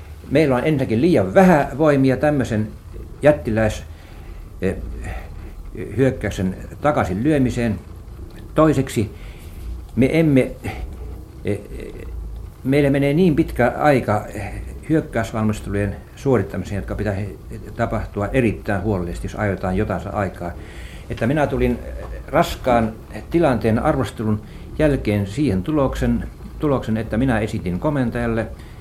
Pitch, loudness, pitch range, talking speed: 110 Hz, -20 LUFS, 95-130 Hz, 90 wpm